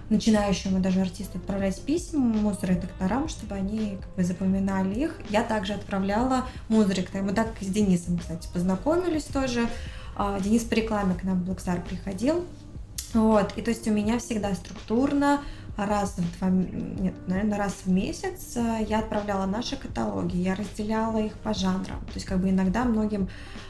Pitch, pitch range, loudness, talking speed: 205 Hz, 190-225 Hz, -27 LUFS, 165 wpm